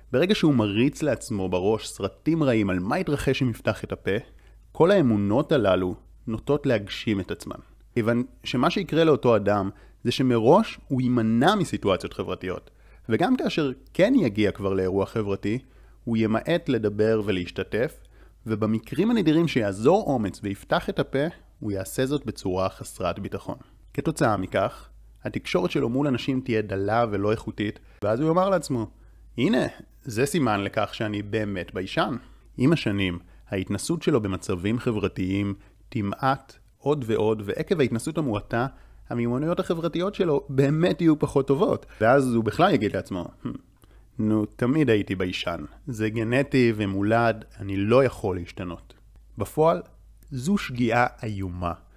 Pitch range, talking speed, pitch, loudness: 100-135 Hz, 135 wpm, 110 Hz, -25 LUFS